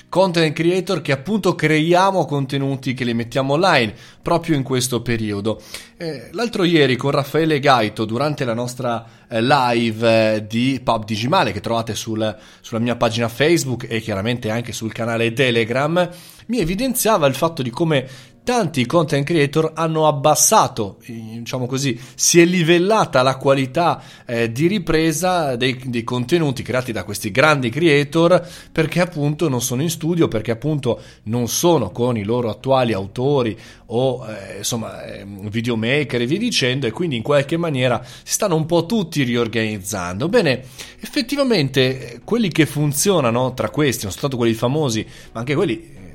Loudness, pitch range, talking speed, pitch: -18 LUFS, 115-165 Hz, 150 wpm, 130 Hz